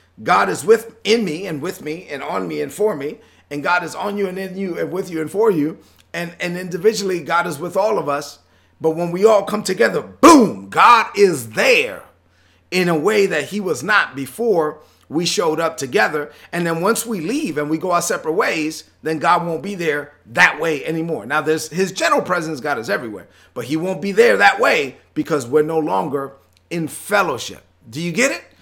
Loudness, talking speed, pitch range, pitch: -18 LUFS, 215 wpm, 150-195 Hz, 165 Hz